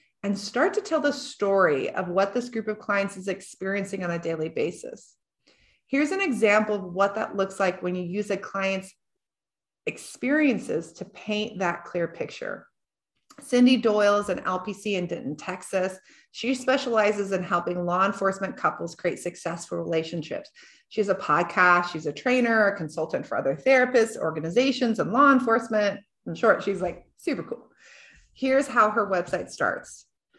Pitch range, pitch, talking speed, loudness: 180-240 Hz, 200 Hz, 160 wpm, -25 LUFS